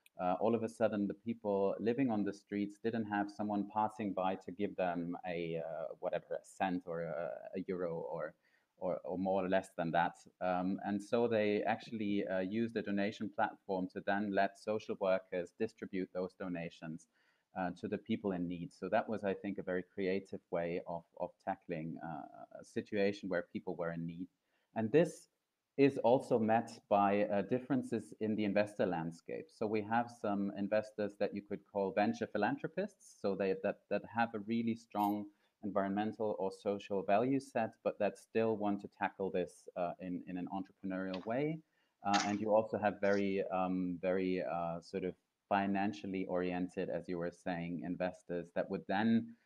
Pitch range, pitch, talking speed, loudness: 95-105 Hz, 100 Hz, 180 wpm, -38 LUFS